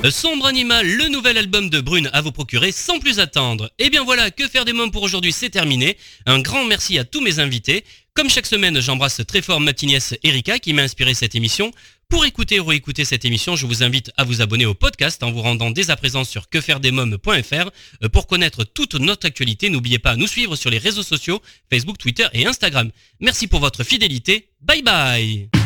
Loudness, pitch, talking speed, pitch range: -16 LUFS, 145 Hz, 215 wpm, 125-200 Hz